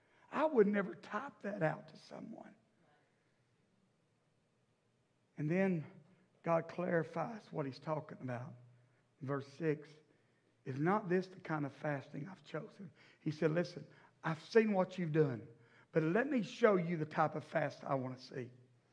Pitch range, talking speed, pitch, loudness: 140-185 Hz, 155 wpm, 155 Hz, -38 LUFS